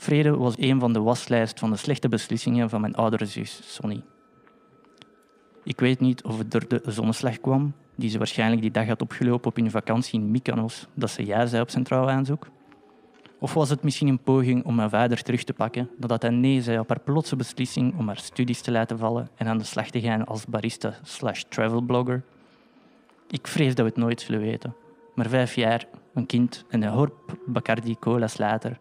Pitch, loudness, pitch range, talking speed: 120 Hz, -25 LUFS, 115-130 Hz, 205 wpm